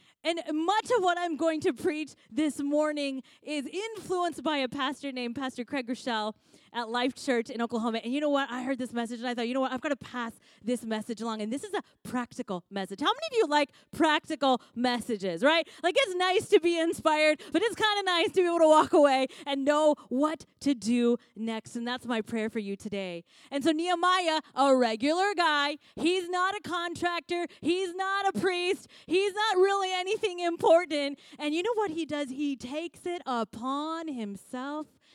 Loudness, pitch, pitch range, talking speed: -29 LUFS, 295 Hz, 245-345 Hz, 205 wpm